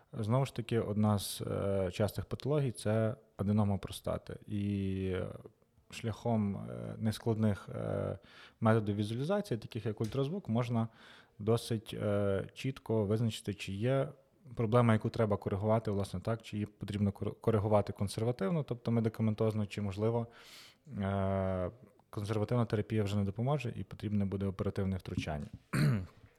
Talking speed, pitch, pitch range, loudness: 110 wpm, 110 Hz, 100-115 Hz, -35 LUFS